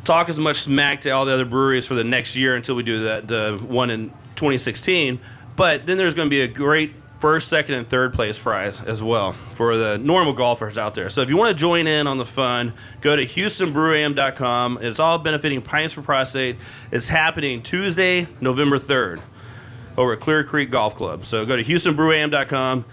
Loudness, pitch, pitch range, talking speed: -20 LUFS, 130 Hz, 120-155 Hz, 200 wpm